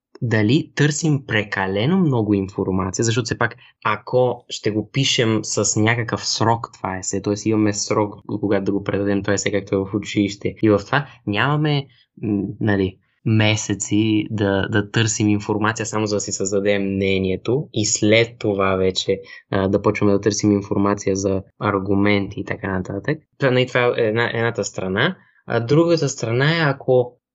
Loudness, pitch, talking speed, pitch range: -20 LUFS, 105 Hz, 160 wpm, 100-120 Hz